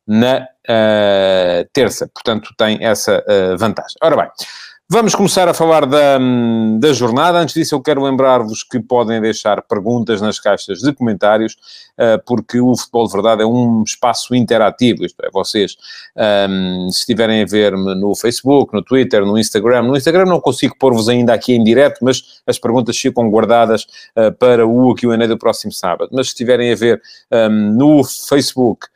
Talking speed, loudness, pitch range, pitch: 170 wpm, -13 LUFS, 110-130 Hz, 120 Hz